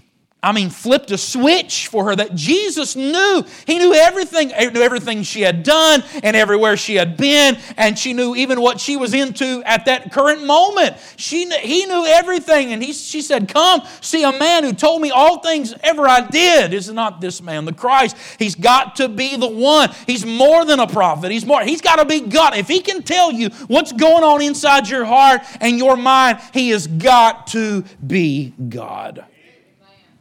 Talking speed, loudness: 195 wpm, -14 LUFS